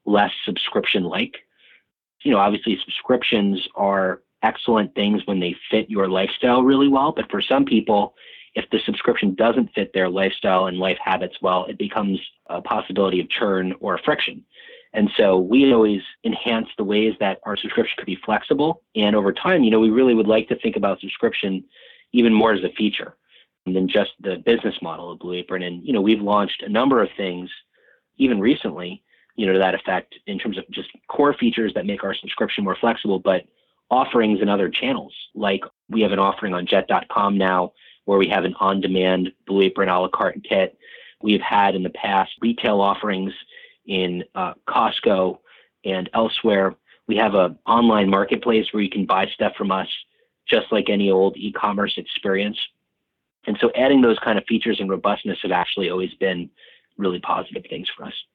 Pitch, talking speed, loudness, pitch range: 100 Hz, 185 wpm, -20 LUFS, 95-110 Hz